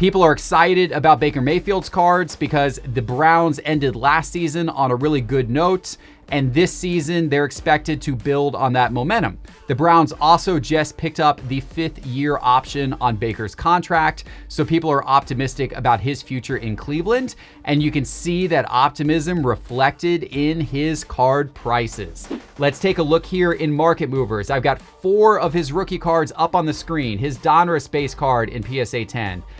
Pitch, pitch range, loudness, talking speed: 150 Hz, 135-165 Hz, -19 LUFS, 175 wpm